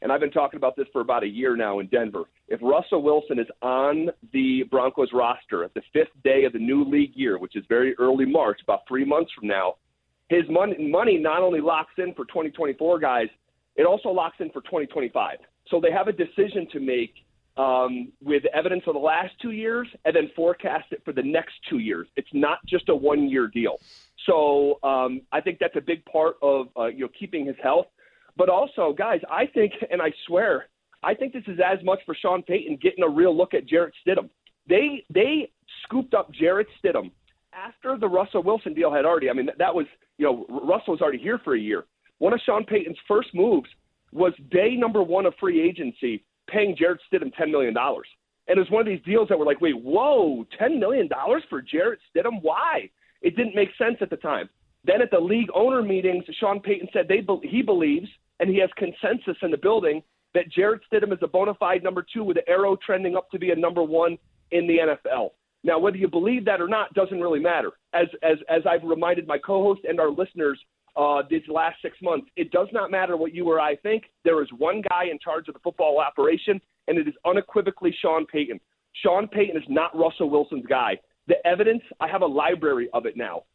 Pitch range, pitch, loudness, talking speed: 160-220 Hz, 180 Hz, -23 LUFS, 220 wpm